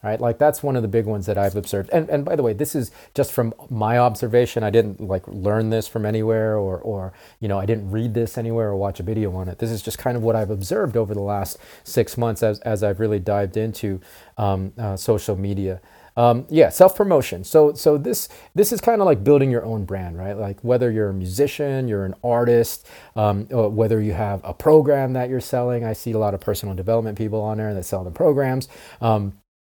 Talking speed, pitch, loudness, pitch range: 235 wpm, 110 Hz, -21 LUFS, 100-120 Hz